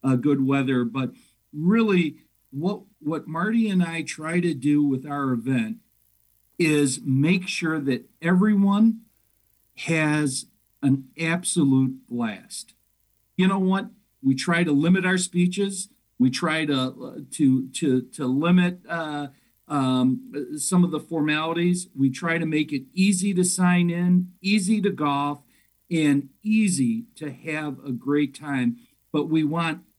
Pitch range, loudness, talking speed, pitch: 135-180 Hz, -23 LUFS, 140 wpm, 155 Hz